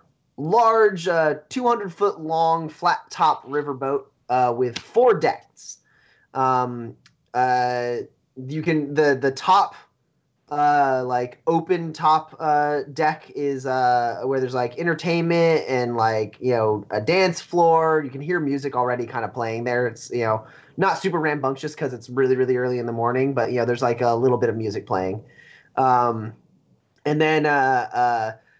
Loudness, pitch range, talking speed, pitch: -22 LUFS, 125-160 Hz, 160 wpm, 135 Hz